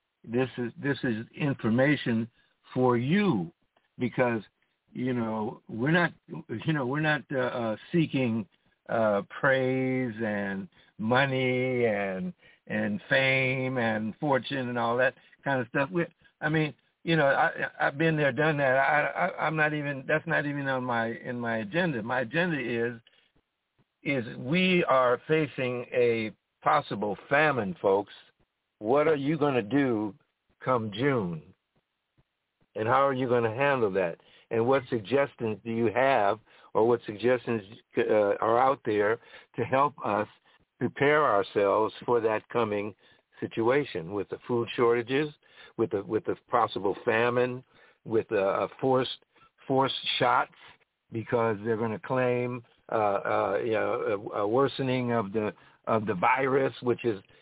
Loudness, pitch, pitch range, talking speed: -28 LUFS, 125 Hz, 115-140 Hz, 145 wpm